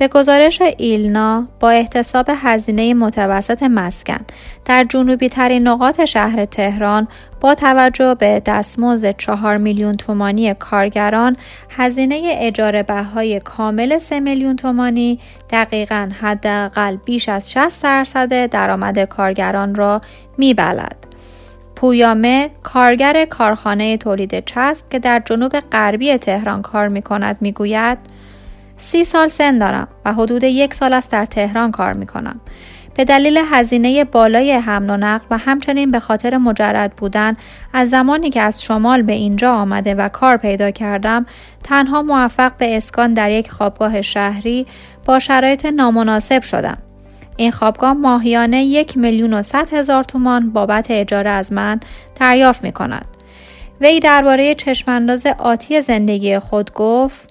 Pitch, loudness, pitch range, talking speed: 235 Hz, -14 LUFS, 210-260 Hz, 130 wpm